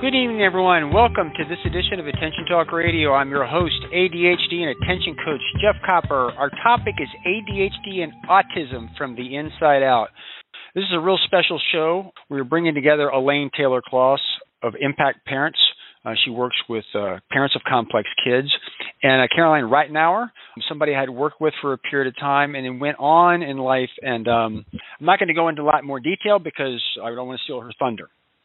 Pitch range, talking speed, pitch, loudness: 135-175 Hz, 200 wpm, 150 Hz, -20 LUFS